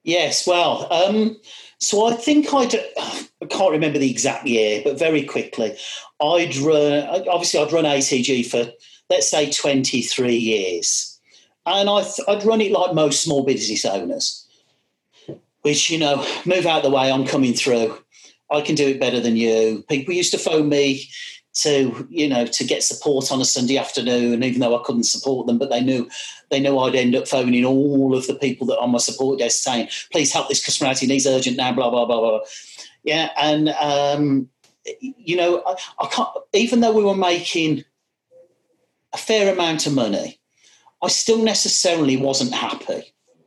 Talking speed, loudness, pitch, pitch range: 180 wpm, -19 LUFS, 145 Hz, 130-175 Hz